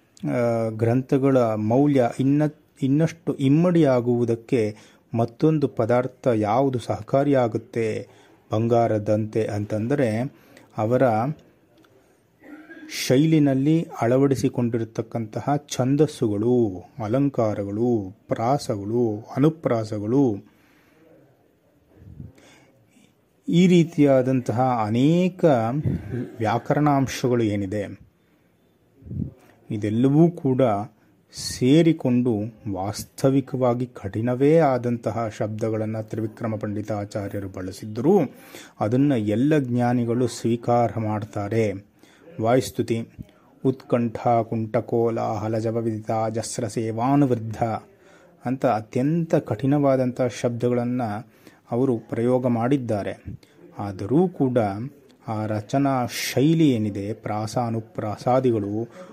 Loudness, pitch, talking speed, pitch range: -23 LUFS, 120 Hz, 60 wpm, 110-135 Hz